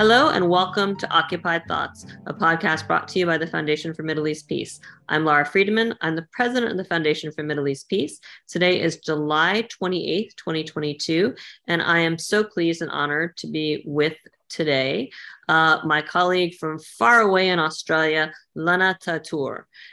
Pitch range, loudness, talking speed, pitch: 155-180 Hz, -22 LUFS, 170 wpm, 165 Hz